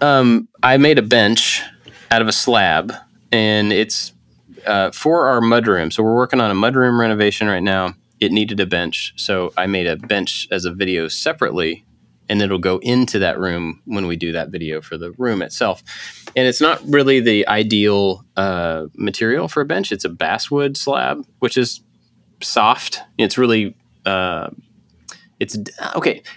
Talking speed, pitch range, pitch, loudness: 175 wpm, 95-125 Hz, 105 Hz, -17 LUFS